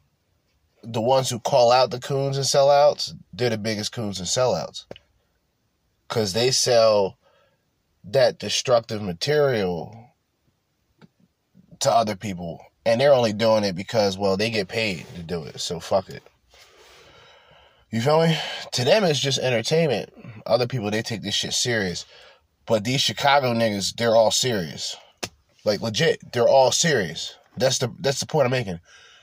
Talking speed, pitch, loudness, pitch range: 150 wpm, 115 Hz, -22 LUFS, 105-135 Hz